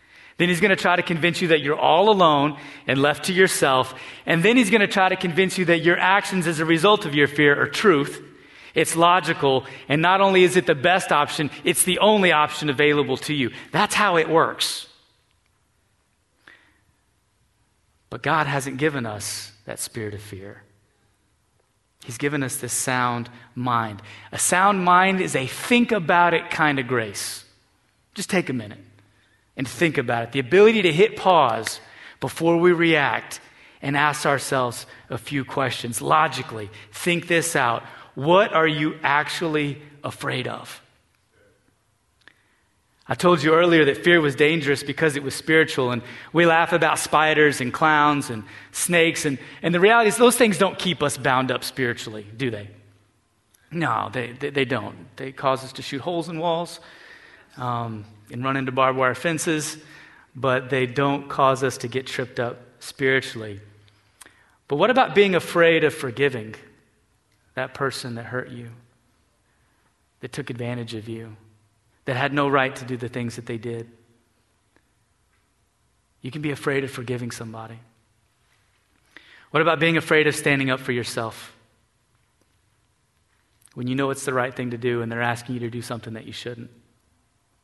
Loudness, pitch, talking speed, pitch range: -21 LUFS, 135 Hz, 165 wpm, 115-160 Hz